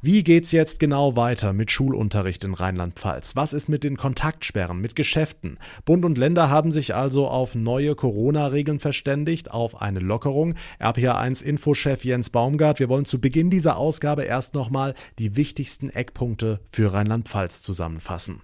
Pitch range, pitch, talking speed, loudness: 110-150 Hz, 135 Hz, 155 wpm, -23 LUFS